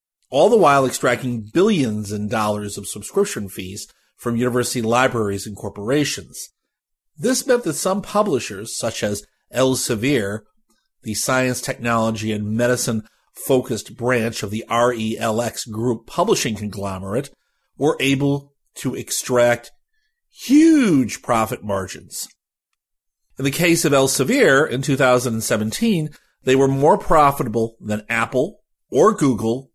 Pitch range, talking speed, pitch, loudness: 110-140 Hz, 115 wpm, 120 Hz, -19 LUFS